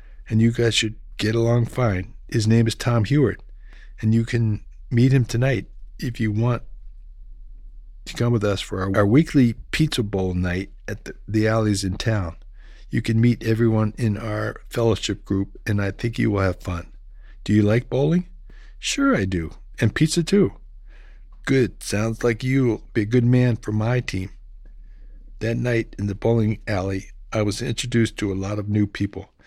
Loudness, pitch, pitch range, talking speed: -22 LUFS, 110 Hz, 100-120 Hz, 180 wpm